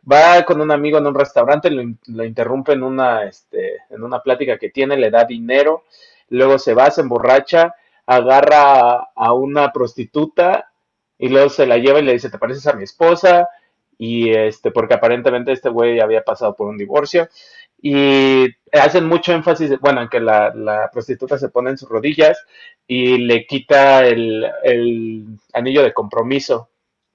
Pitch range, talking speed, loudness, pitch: 120-155 Hz, 175 wpm, -14 LUFS, 135 Hz